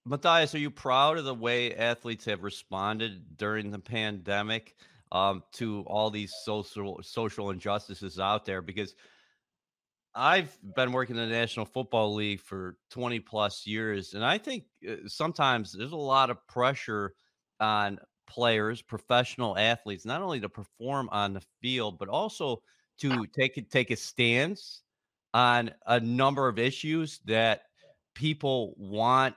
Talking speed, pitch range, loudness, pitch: 145 wpm, 105-130 Hz, -29 LUFS, 115 Hz